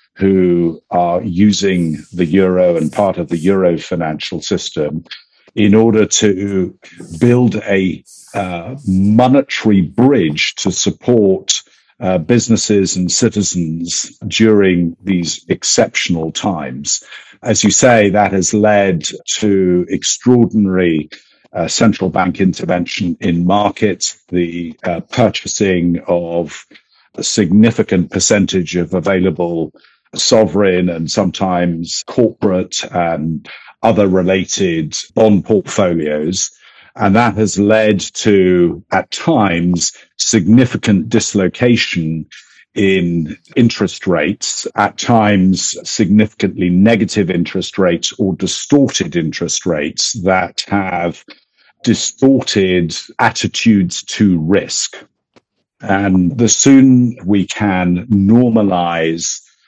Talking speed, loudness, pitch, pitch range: 95 wpm, -13 LUFS, 95 Hz, 90-110 Hz